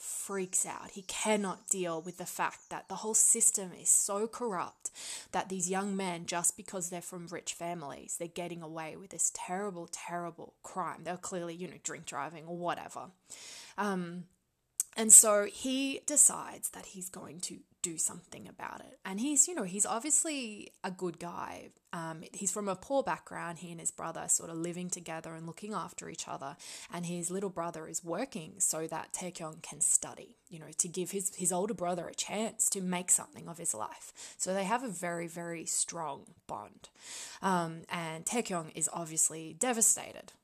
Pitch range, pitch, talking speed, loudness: 170-205 Hz, 180 Hz, 185 wpm, -31 LUFS